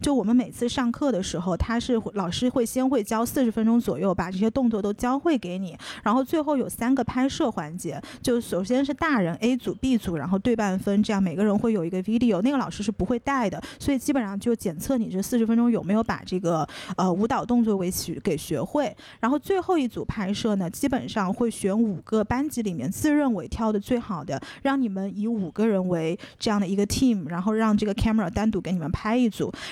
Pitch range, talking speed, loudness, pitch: 195-250 Hz, 355 characters per minute, -25 LUFS, 220 Hz